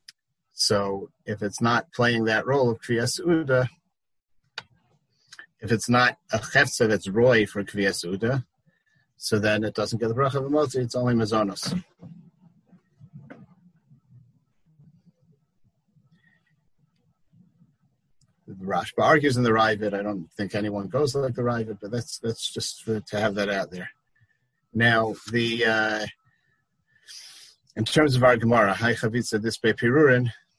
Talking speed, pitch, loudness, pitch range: 125 wpm, 120 Hz, -24 LUFS, 110-150 Hz